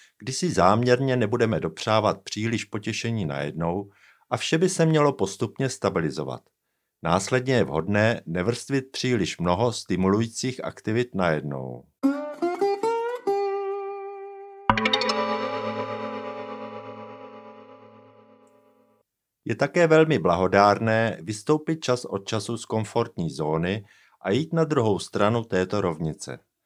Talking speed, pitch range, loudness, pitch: 95 wpm, 100-150 Hz, -25 LUFS, 115 Hz